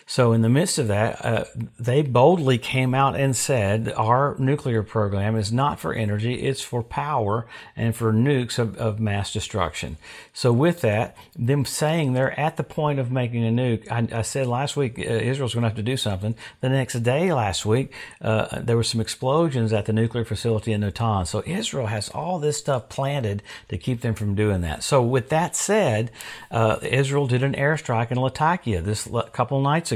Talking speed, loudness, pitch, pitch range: 200 wpm, -23 LUFS, 120 Hz, 110-135 Hz